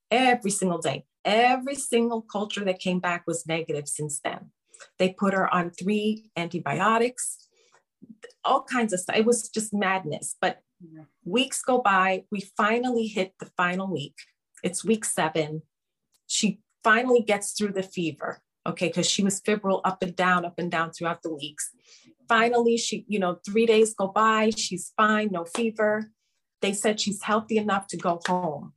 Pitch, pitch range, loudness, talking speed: 200 Hz, 175-220 Hz, -25 LUFS, 165 wpm